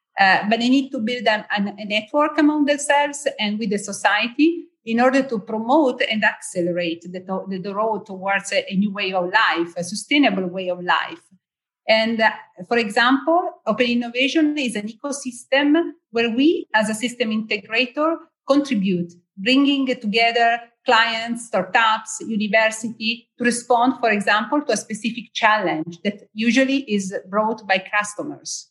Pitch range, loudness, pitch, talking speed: 205-260 Hz, -20 LUFS, 225 Hz, 155 wpm